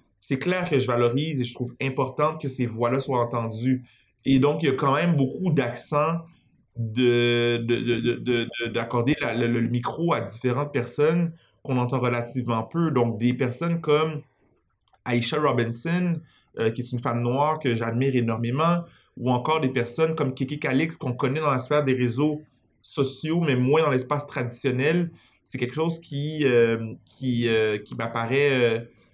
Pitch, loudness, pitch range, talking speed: 130 Hz, -25 LUFS, 120-150 Hz, 175 wpm